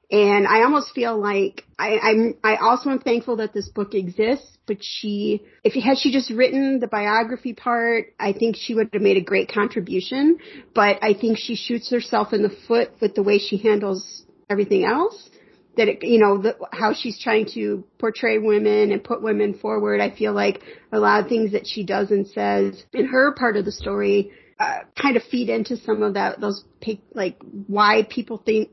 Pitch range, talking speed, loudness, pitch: 205-235 Hz, 205 wpm, -21 LUFS, 215 Hz